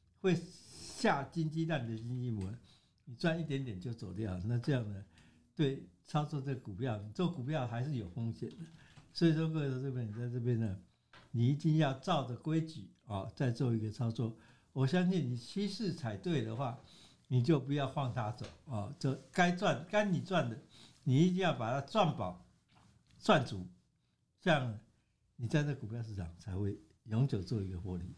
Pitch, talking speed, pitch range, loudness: 125 Hz, 260 characters per minute, 110-155 Hz, -36 LUFS